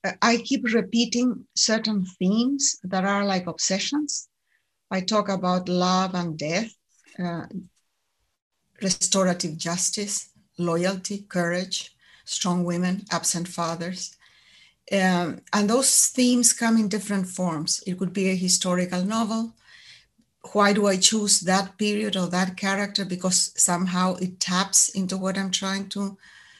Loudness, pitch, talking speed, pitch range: -23 LUFS, 190 Hz, 125 wpm, 180-210 Hz